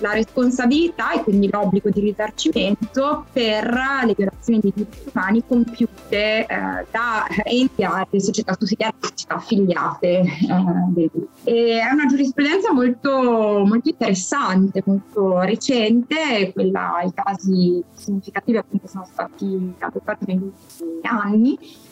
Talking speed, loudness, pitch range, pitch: 120 wpm, -20 LUFS, 195-250 Hz, 215 Hz